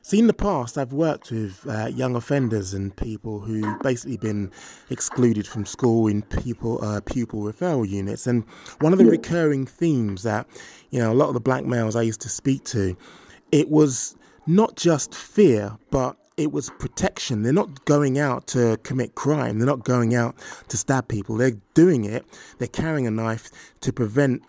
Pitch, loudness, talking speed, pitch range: 120 Hz, -23 LUFS, 200 wpm, 110-140 Hz